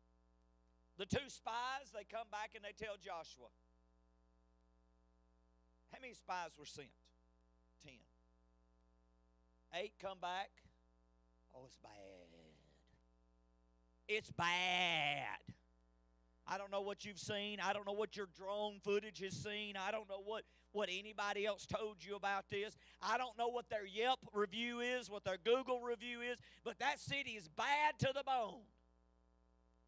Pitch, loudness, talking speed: 180 Hz, -43 LUFS, 145 wpm